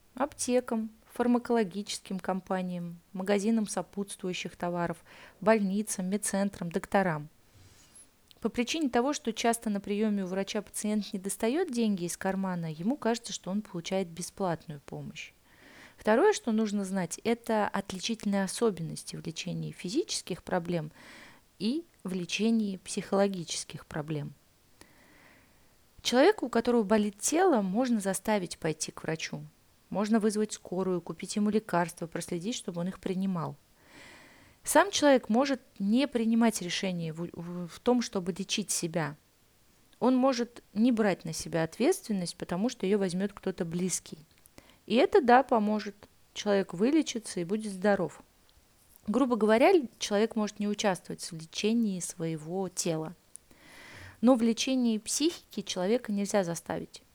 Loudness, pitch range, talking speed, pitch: -30 LUFS, 180-230 Hz, 125 wpm, 200 Hz